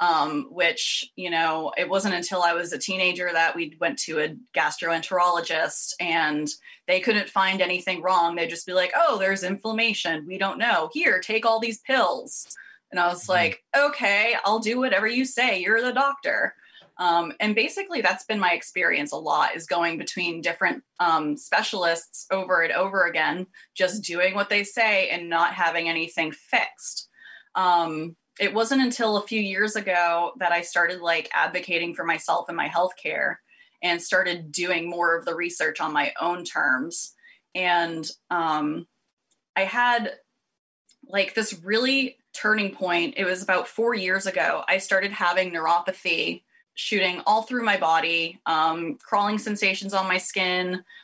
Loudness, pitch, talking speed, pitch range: -24 LUFS, 185 Hz, 165 wpm, 170-220 Hz